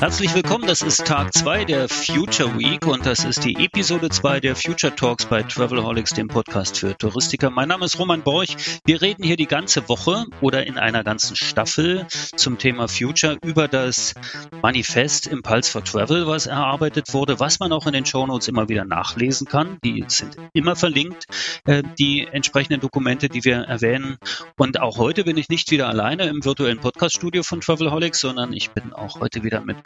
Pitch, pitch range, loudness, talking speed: 140 Hz, 125-160 Hz, -20 LUFS, 185 wpm